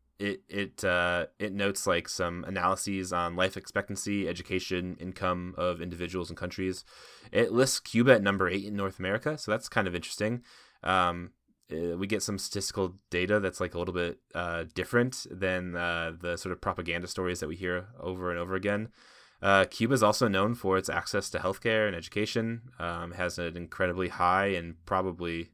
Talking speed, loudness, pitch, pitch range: 180 wpm, -30 LUFS, 95 Hz, 90-100 Hz